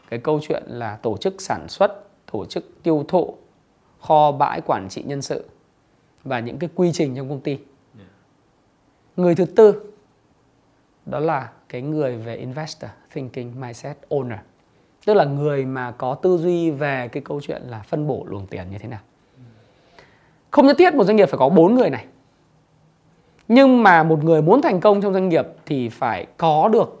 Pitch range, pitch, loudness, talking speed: 125-175 Hz, 150 Hz, -19 LUFS, 180 wpm